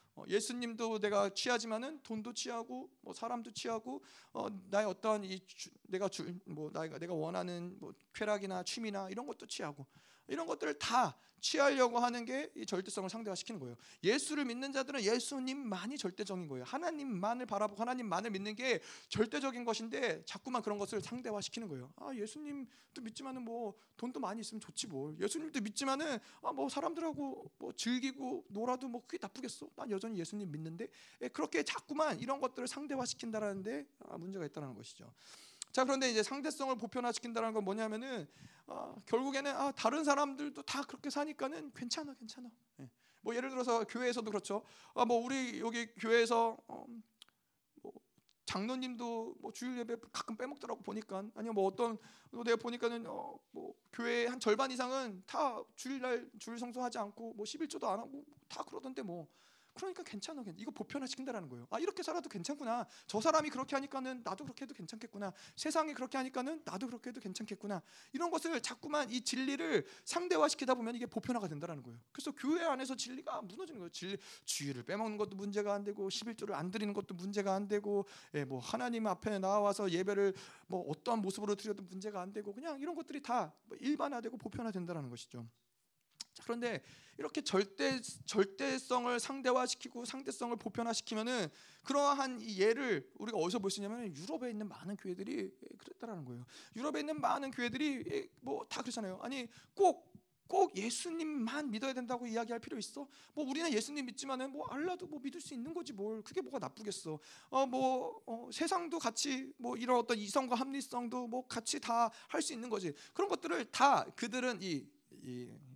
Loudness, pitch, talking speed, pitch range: -39 LUFS, 235 Hz, 395 characters per minute, 205-270 Hz